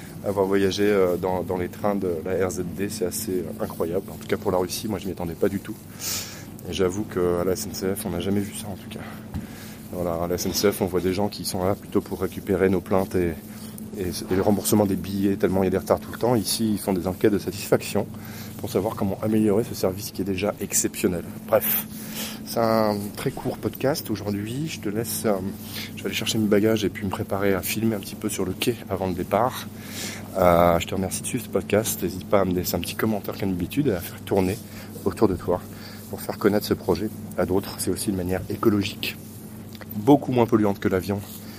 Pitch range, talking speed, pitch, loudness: 95-110 Hz, 230 wpm, 100 Hz, -25 LUFS